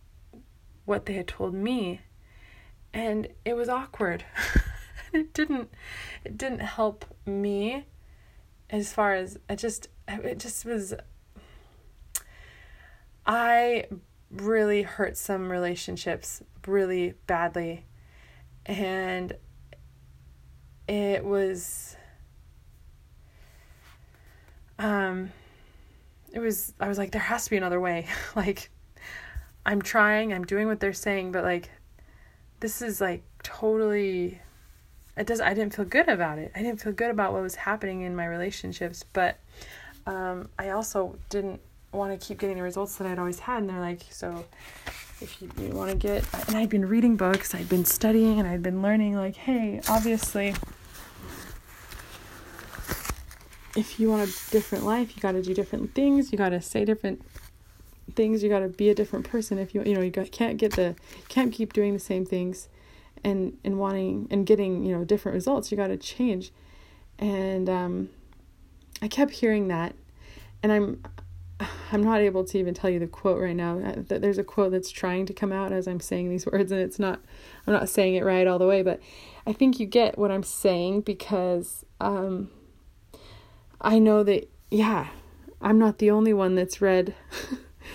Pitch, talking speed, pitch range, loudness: 195 Hz, 160 wpm, 175-215 Hz, -27 LUFS